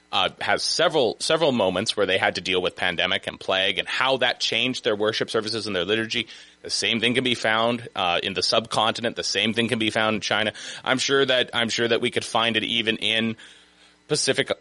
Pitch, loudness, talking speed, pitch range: 110 Hz, -22 LUFS, 235 wpm, 105-120 Hz